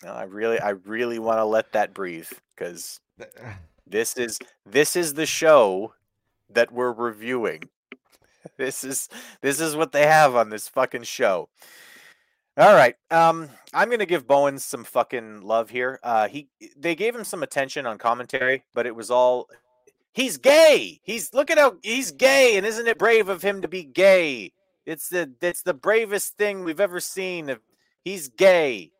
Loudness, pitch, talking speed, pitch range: -21 LUFS, 150 Hz, 170 wpm, 120-195 Hz